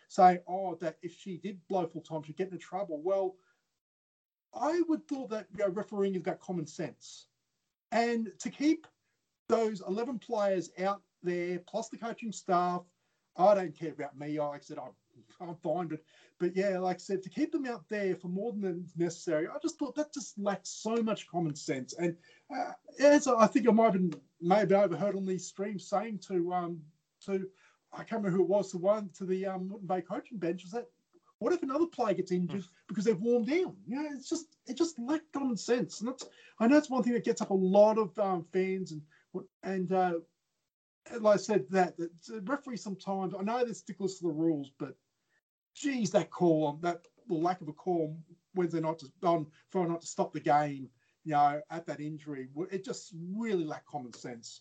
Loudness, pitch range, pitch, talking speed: -32 LUFS, 170-220 Hz, 190 Hz, 205 wpm